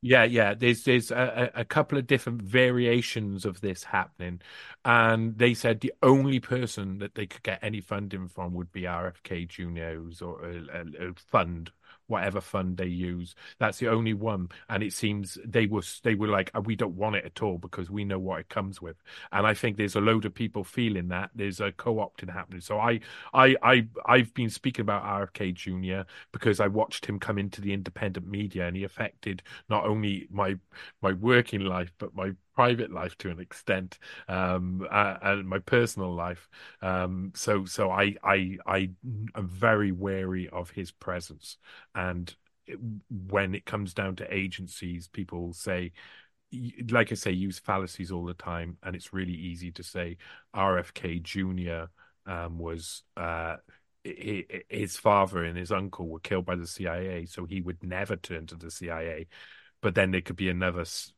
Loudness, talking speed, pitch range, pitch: -29 LUFS, 180 wpm, 90-110 Hz, 95 Hz